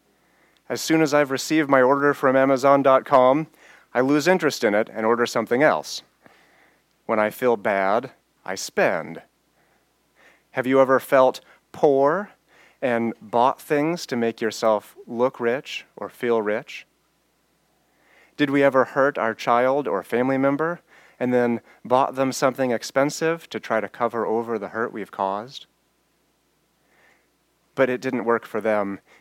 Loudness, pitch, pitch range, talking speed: -22 LUFS, 130 Hz, 115-140 Hz, 145 wpm